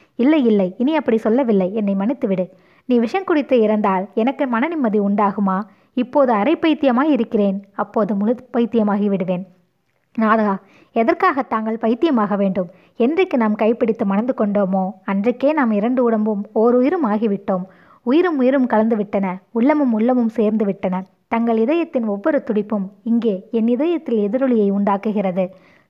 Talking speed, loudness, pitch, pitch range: 125 wpm, -18 LUFS, 225 Hz, 200-255 Hz